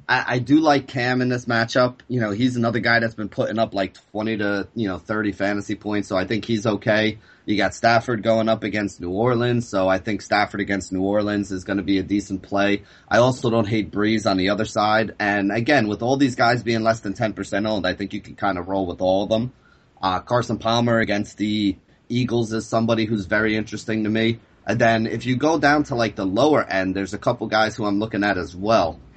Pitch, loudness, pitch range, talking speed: 110 Hz, -21 LUFS, 100-115 Hz, 240 wpm